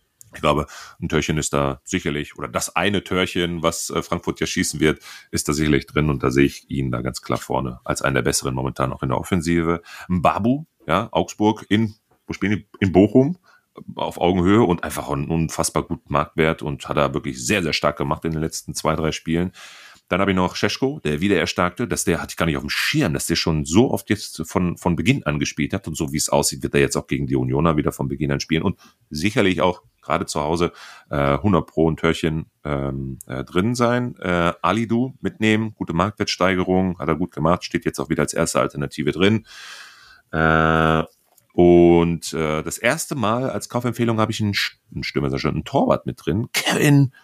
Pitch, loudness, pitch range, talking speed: 85 Hz, -21 LUFS, 75-95 Hz, 200 wpm